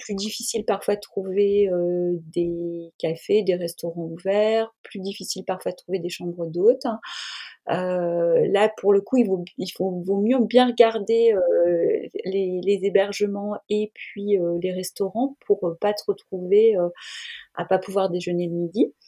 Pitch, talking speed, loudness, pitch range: 195 Hz, 175 wpm, -23 LUFS, 175-220 Hz